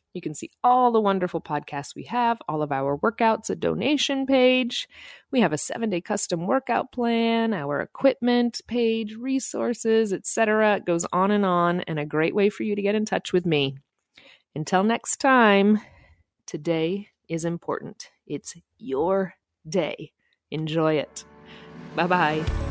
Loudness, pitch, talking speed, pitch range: -24 LUFS, 190 Hz, 150 wpm, 155-230 Hz